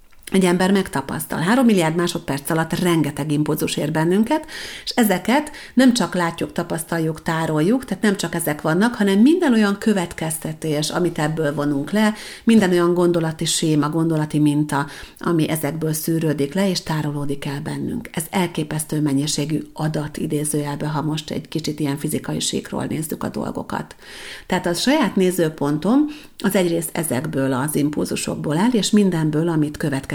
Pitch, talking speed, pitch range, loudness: 165 Hz, 145 wpm, 150-190 Hz, -20 LUFS